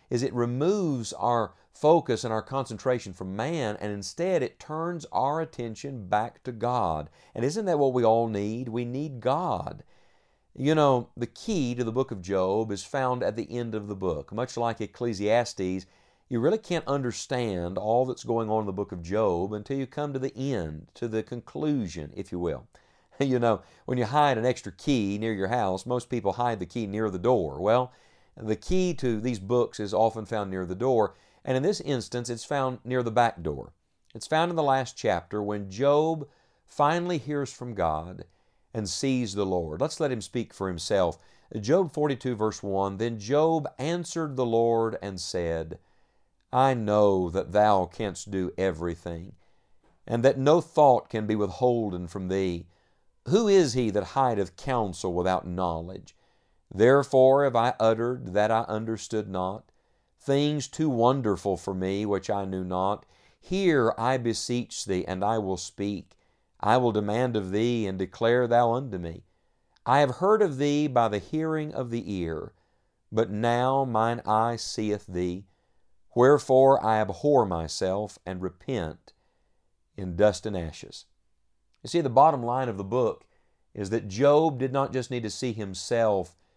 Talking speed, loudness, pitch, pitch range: 175 wpm, -27 LUFS, 115 Hz, 100-130 Hz